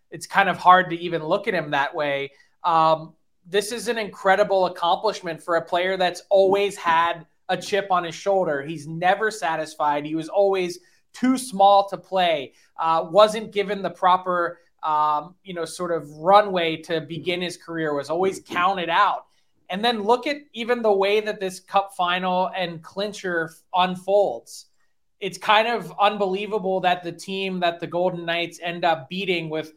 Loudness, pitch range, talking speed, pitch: -22 LUFS, 165-195 Hz, 175 wpm, 180 Hz